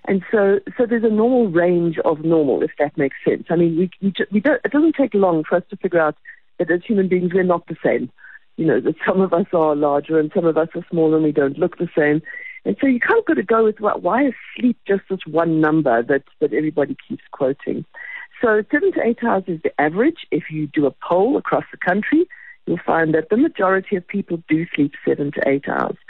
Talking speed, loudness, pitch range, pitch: 245 wpm, -19 LUFS, 160-220 Hz, 180 Hz